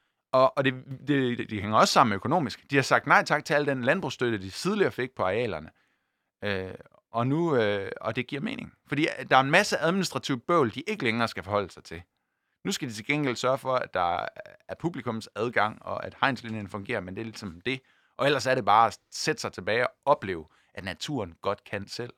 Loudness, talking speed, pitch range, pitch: -27 LUFS, 220 wpm, 105-140 Hz, 125 Hz